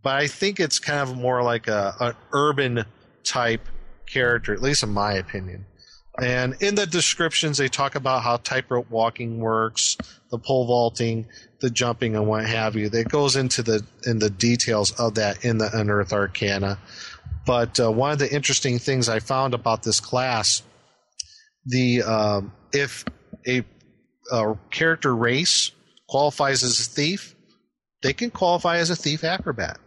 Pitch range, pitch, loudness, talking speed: 110-135 Hz, 120 Hz, -22 LUFS, 165 wpm